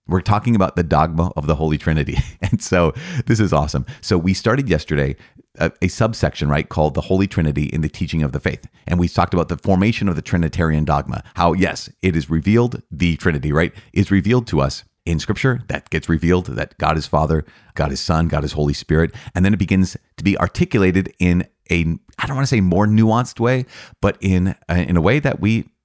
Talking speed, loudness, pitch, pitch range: 220 wpm, -19 LUFS, 90 Hz, 80-105 Hz